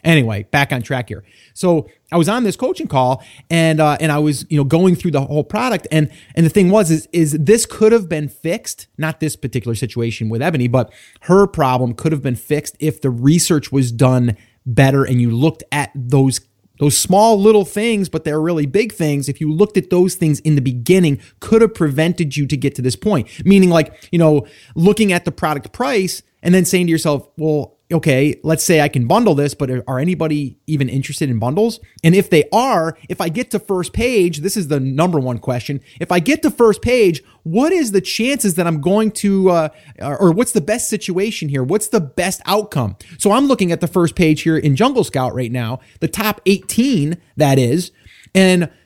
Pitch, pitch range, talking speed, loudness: 160 Hz, 135-190 Hz, 215 wpm, -16 LUFS